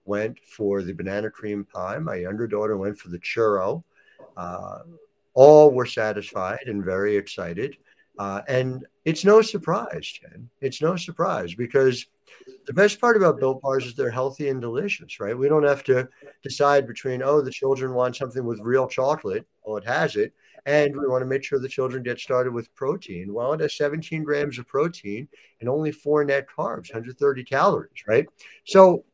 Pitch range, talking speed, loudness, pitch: 120-150 Hz, 180 wpm, -23 LUFS, 135 Hz